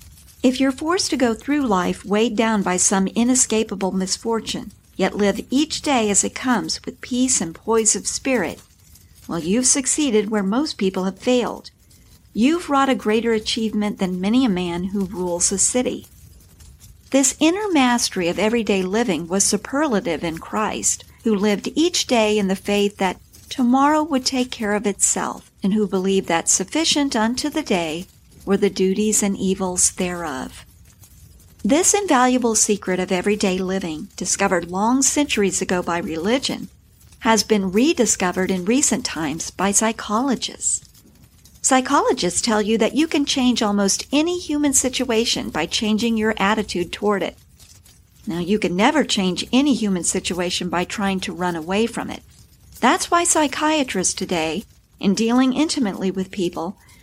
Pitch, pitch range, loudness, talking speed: 210 Hz, 190-255 Hz, -19 LUFS, 155 wpm